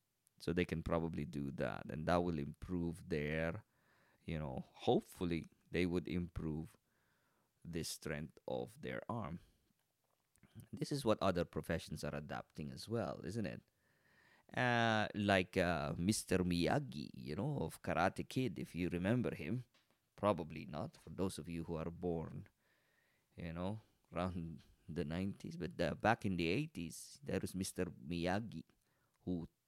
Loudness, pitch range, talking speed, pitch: -41 LUFS, 80-100 Hz, 145 wpm, 90 Hz